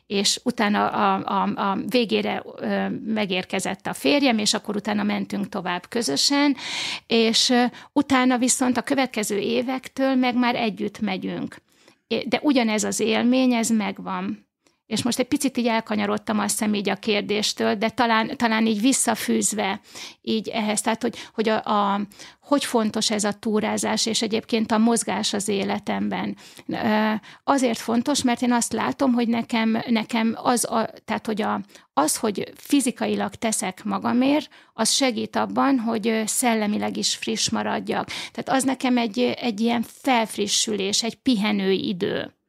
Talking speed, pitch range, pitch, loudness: 145 wpm, 210-245 Hz, 225 Hz, -23 LUFS